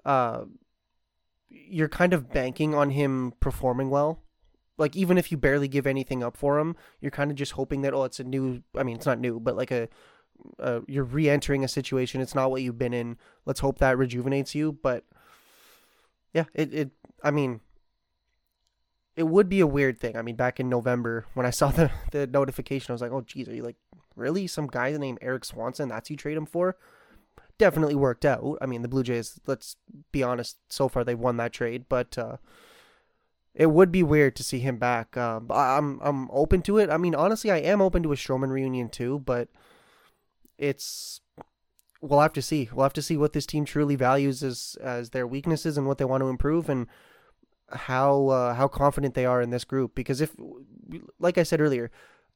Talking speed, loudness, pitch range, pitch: 205 wpm, -26 LUFS, 125-150 Hz, 135 Hz